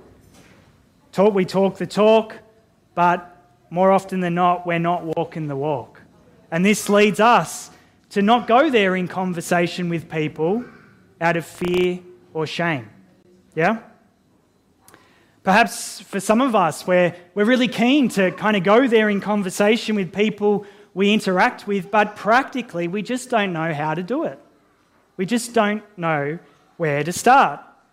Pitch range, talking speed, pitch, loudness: 170-210 Hz, 155 wpm, 185 Hz, -19 LUFS